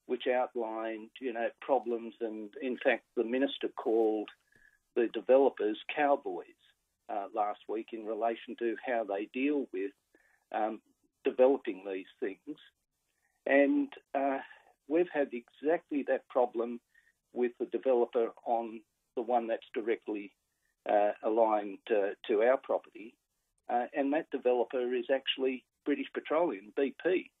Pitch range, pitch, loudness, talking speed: 115-145 Hz, 125 Hz, -33 LUFS, 125 wpm